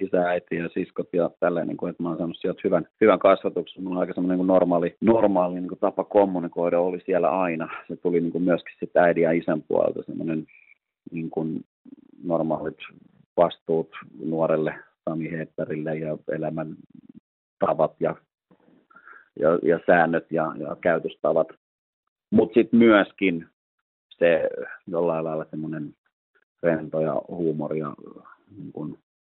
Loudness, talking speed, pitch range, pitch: -24 LUFS, 145 wpm, 80-90 Hz, 85 Hz